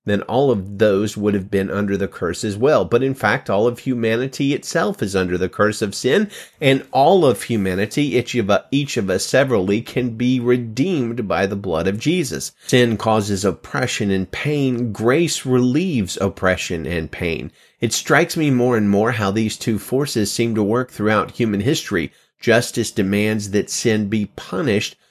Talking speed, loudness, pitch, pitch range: 180 wpm, -19 LUFS, 110 Hz, 100-125 Hz